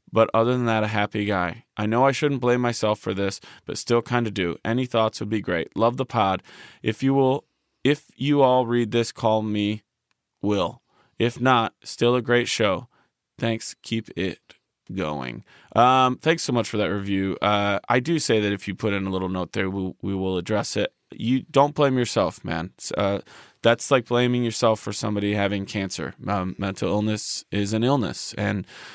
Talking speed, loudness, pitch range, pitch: 195 wpm, -23 LUFS, 100-125 Hz, 110 Hz